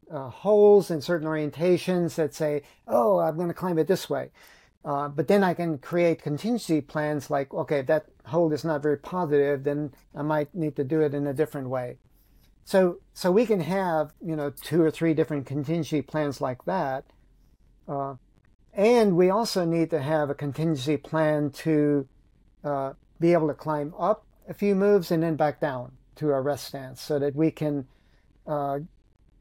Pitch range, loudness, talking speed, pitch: 145-170 Hz, -26 LUFS, 185 wpm, 155 Hz